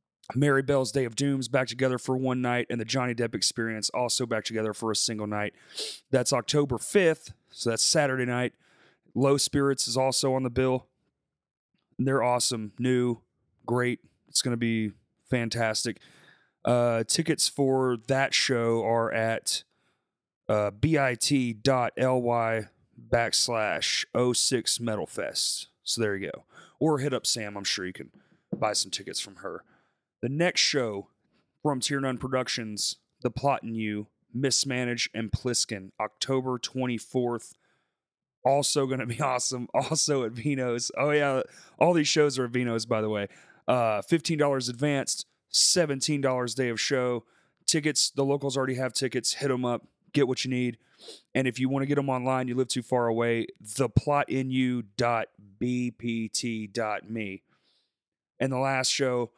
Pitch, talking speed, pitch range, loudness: 125 Hz, 150 wpm, 115-135 Hz, -27 LUFS